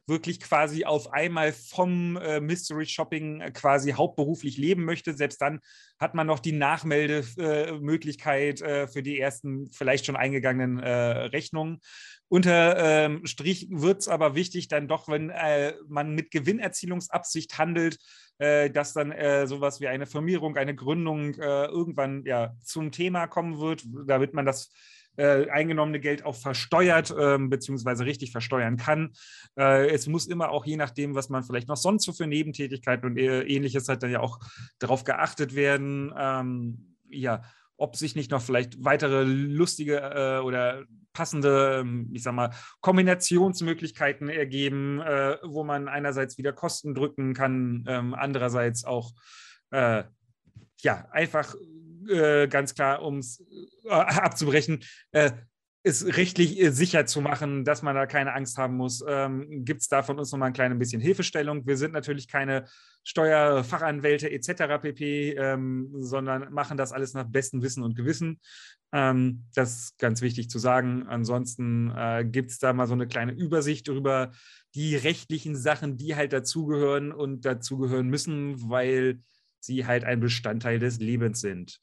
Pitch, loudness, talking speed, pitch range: 140 Hz, -27 LUFS, 145 wpm, 130-155 Hz